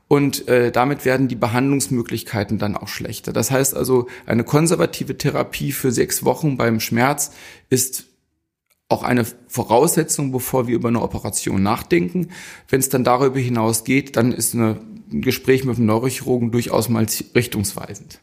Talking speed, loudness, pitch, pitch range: 155 wpm, -19 LUFS, 125 Hz, 115-135 Hz